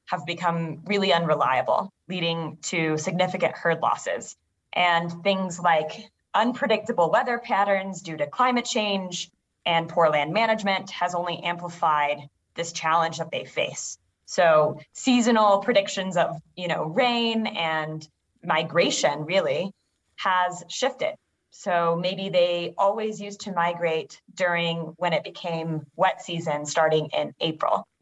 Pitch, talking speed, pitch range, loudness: 175 Hz, 125 wpm, 160-200 Hz, -24 LUFS